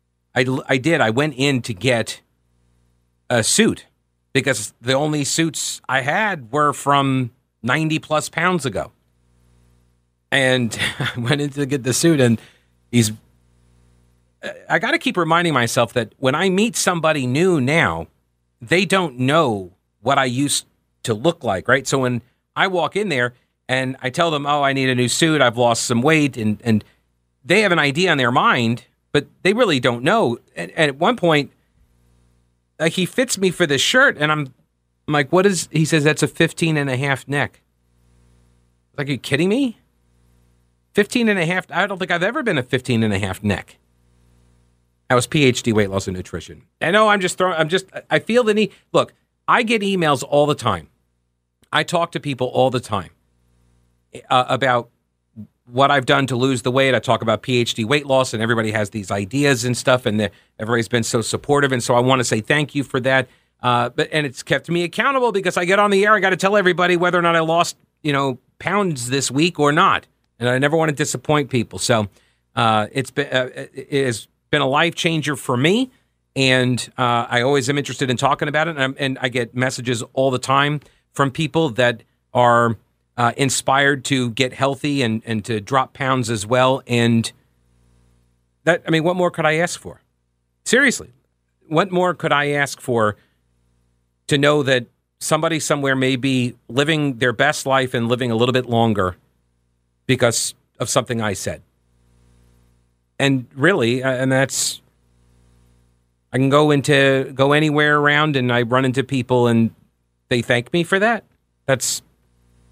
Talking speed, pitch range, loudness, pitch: 190 wpm, 100-150 Hz, -18 LUFS, 130 Hz